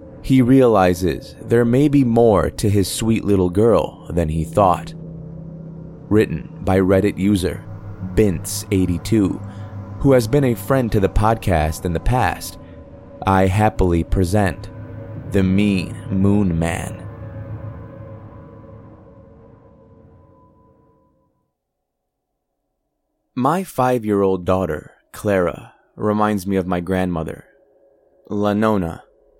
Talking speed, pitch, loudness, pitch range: 100 wpm, 105 Hz, -18 LUFS, 95-110 Hz